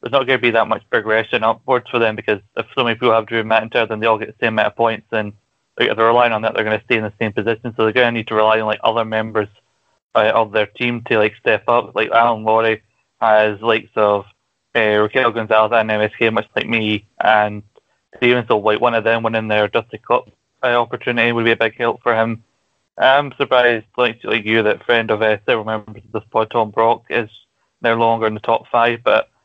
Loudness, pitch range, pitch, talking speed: -17 LUFS, 110-115 Hz, 115 Hz, 250 wpm